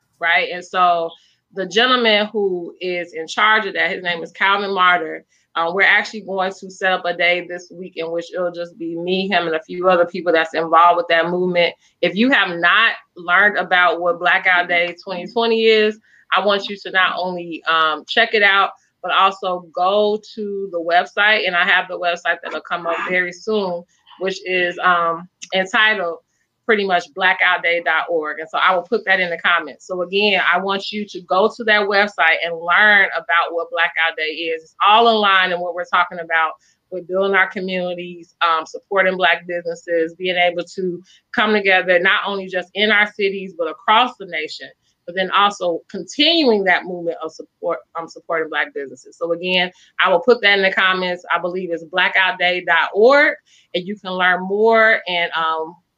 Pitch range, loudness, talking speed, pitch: 170-195 Hz, -17 LUFS, 190 wpm, 180 Hz